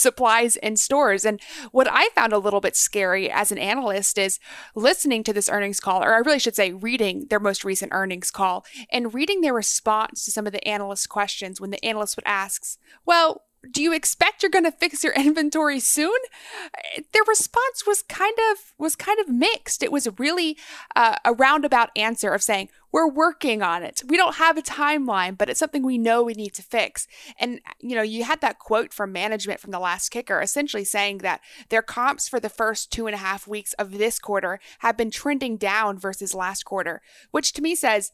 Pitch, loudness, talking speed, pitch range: 230 Hz, -22 LUFS, 210 wpm, 205-295 Hz